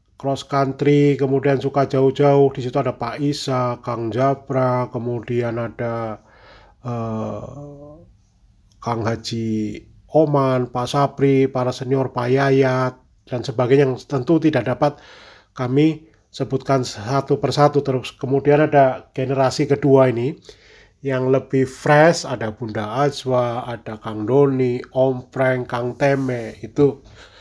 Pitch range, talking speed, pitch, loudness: 120-140 Hz, 120 wpm, 130 Hz, -19 LUFS